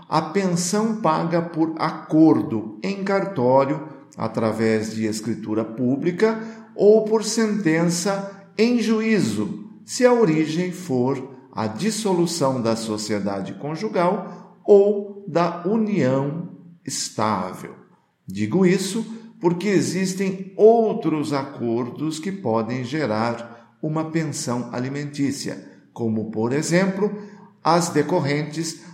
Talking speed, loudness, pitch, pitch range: 95 wpm, -22 LUFS, 160 Hz, 130-195 Hz